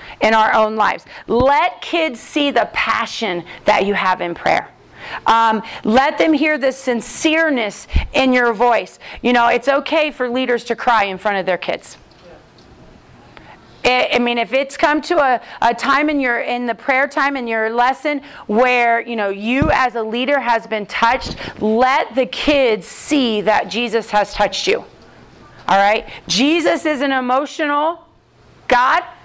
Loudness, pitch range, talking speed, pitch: -16 LUFS, 220-280 Hz, 165 wpm, 245 Hz